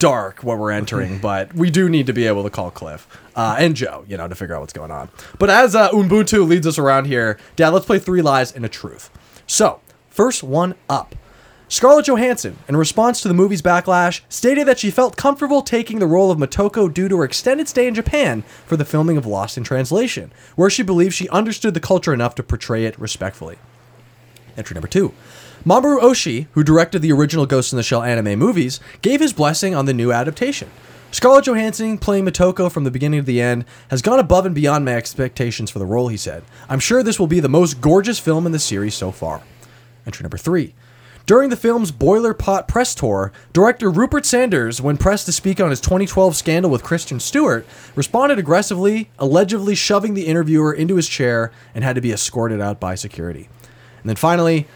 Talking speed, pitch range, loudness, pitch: 210 wpm, 120-200 Hz, -16 LUFS, 160 Hz